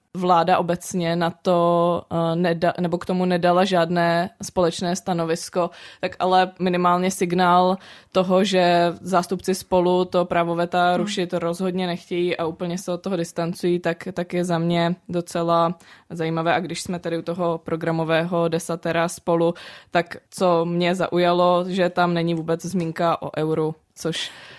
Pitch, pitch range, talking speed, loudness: 175 Hz, 170-180 Hz, 140 wpm, -22 LUFS